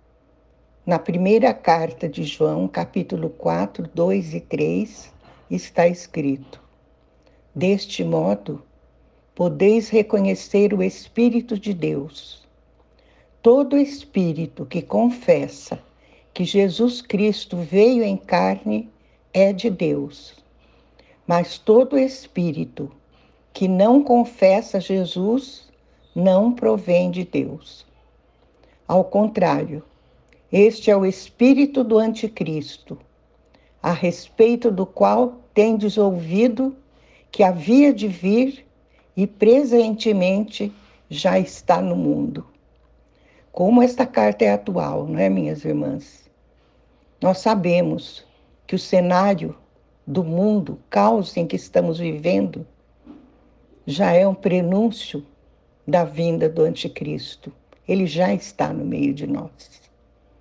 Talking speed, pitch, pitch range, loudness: 105 wpm, 190 Hz, 160-220 Hz, -20 LUFS